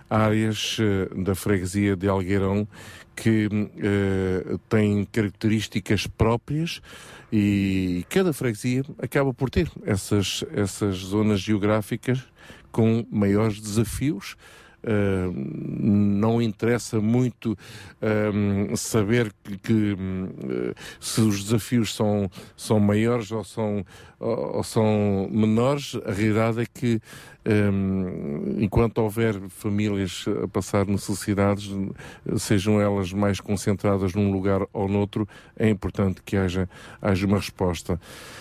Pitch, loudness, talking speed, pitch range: 105 Hz, -24 LUFS, 105 wpm, 100-110 Hz